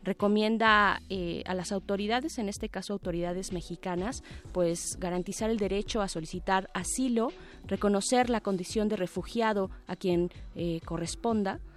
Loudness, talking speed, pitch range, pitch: -30 LUFS, 135 wpm, 180-215 Hz, 195 Hz